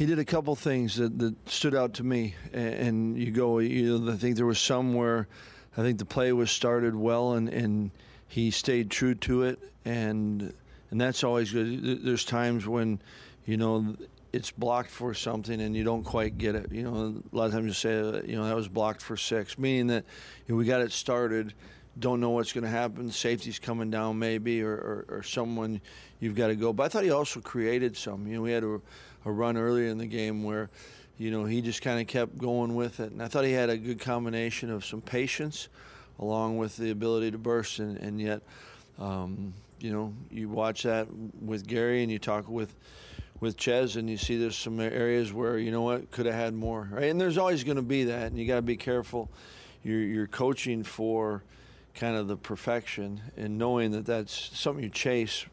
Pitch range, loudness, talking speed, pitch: 110-120 Hz, -30 LUFS, 220 wpm, 115 Hz